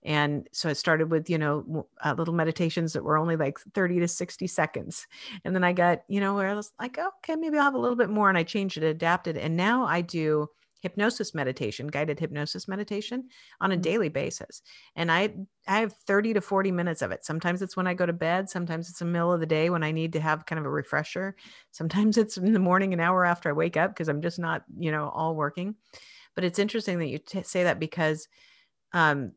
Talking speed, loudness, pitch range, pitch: 240 wpm, -27 LUFS, 160-200 Hz, 175 Hz